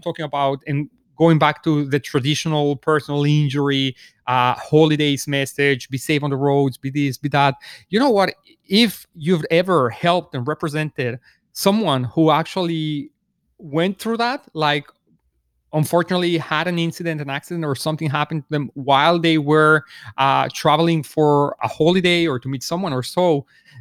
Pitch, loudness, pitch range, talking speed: 150 Hz, -19 LUFS, 140-165 Hz, 160 wpm